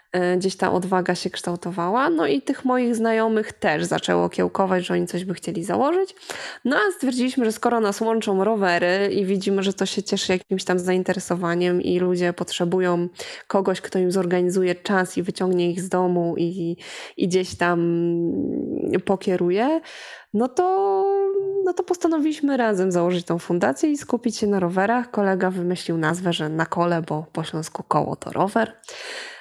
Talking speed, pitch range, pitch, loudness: 165 wpm, 175-230 Hz, 185 Hz, -22 LUFS